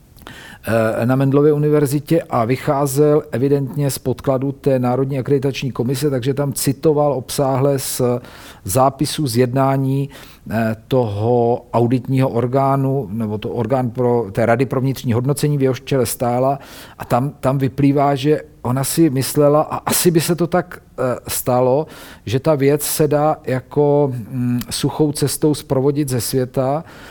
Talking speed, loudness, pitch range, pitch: 135 wpm, -17 LUFS, 125-145 Hz, 135 Hz